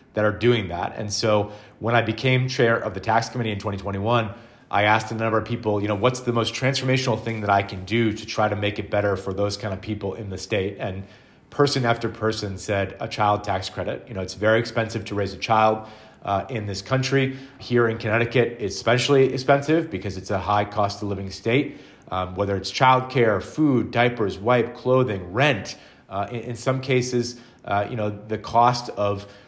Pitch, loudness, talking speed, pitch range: 110 Hz, -23 LUFS, 210 wpm, 100-120 Hz